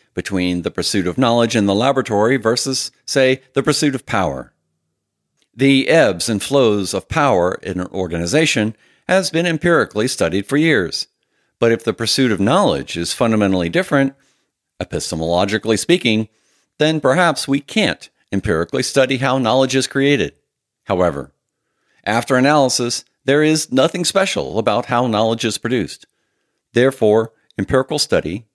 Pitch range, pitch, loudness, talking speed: 105-140 Hz, 120 Hz, -17 LUFS, 135 wpm